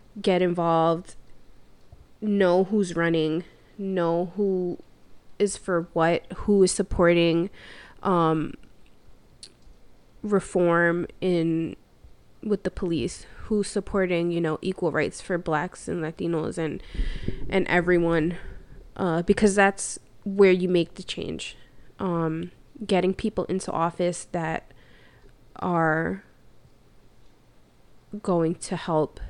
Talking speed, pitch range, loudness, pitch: 100 wpm, 165-190 Hz, -25 LUFS, 175 Hz